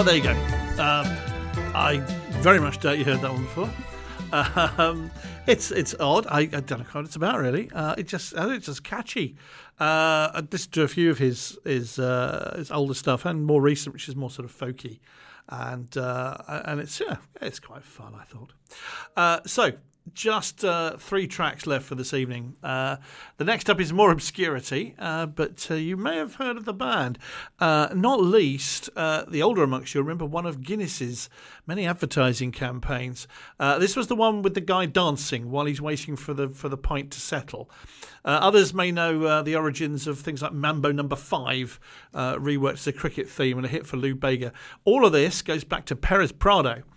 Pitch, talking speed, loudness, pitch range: 150 Hz, 200 wpm, -25 LUFS, 135-170 Hz